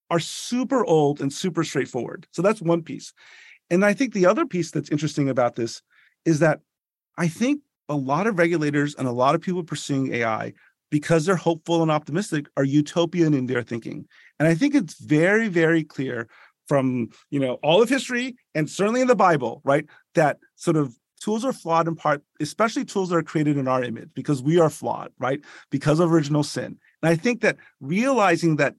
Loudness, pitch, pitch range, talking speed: -23 LUFS, 160 Hz, 145-180 Hz, 200 wpm